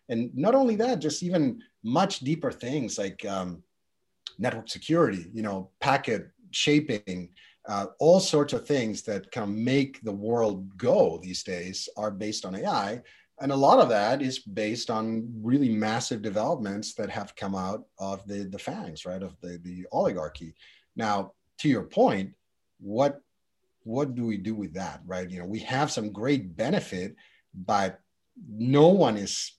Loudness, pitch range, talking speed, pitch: -27 LUFS, 95-140 Hz, 165 wpm, 110 Hz